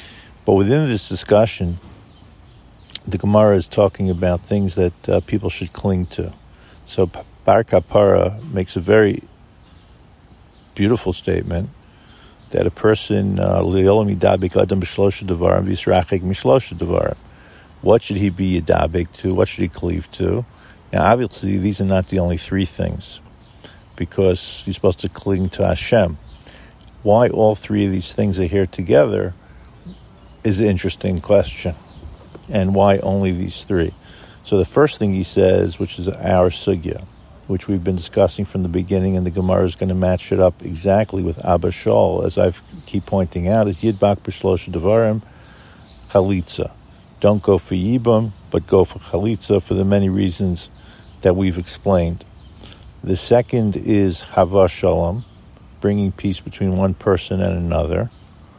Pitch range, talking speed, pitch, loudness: 90-100 Hz, 145 wpm, 95 Hz, -18 LUFS